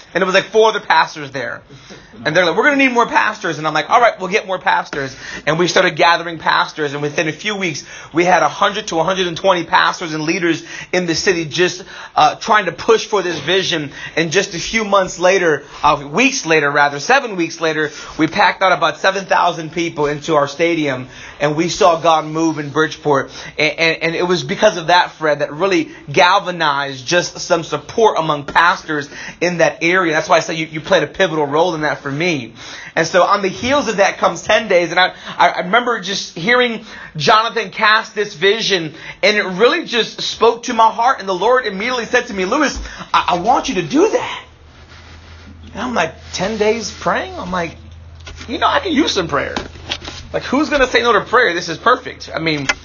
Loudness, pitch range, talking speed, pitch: -15 LUFS, 155-205 Hz, 225 wpm, 175 Hz